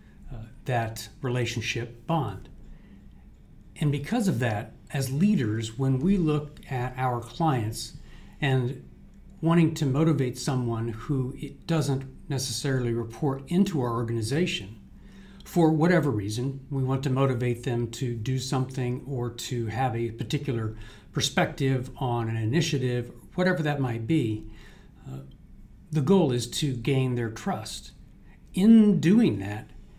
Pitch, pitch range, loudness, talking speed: 130 Hz, 115-150 Hz, -27 LUFS, 130 wpm